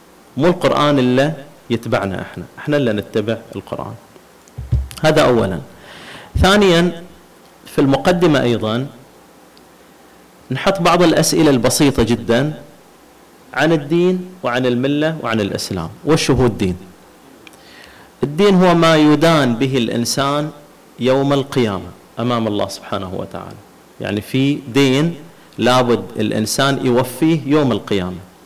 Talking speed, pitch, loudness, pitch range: 105 wpm, 130 Hz, -16 LUFS, 115-150 Hz